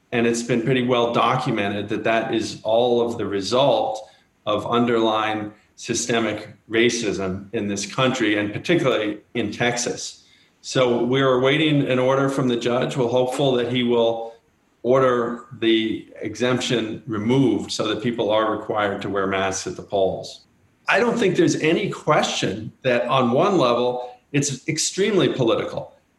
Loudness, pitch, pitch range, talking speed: -21 LUFS, 120 Hz, 110-125 Hz, 150 wpm